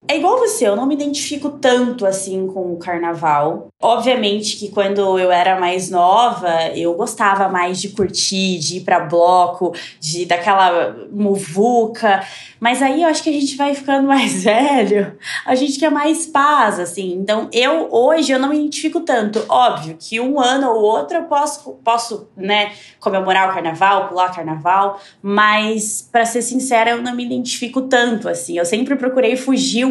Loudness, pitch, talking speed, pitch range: -16 LUFS, 215 Hz, 175 wpm, 190-260 Hz